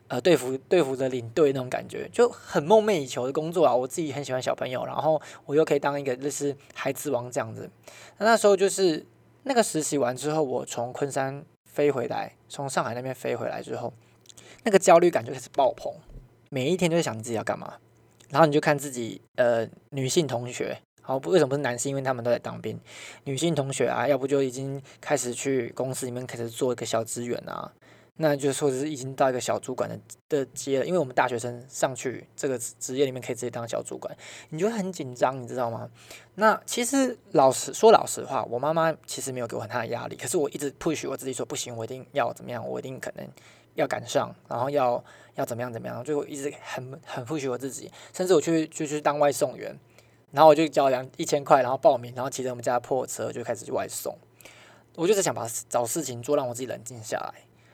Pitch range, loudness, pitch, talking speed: 125-155 Hz, -26 LUFS, 135 Hz, 345 characters per minute